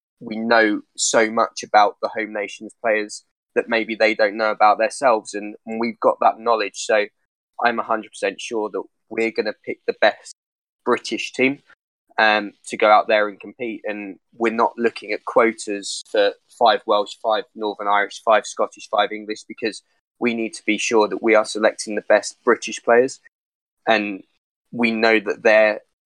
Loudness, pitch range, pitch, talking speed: -20 LUFS, 105-115 Hz, 110 Hz, 175 wpm